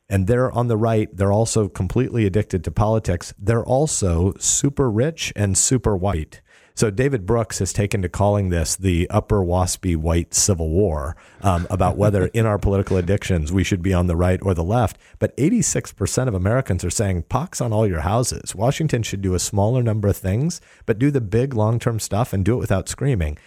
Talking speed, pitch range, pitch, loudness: 200 wpm, 95-115 Hz, 100 Hz, -20 LUFS